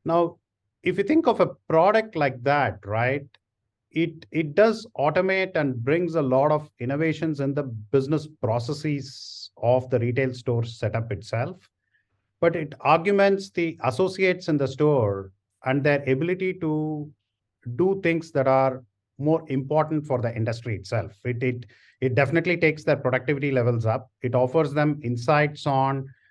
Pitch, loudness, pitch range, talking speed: 140 Hz, -24 LUFS, 125-160 Hz, 150 wpm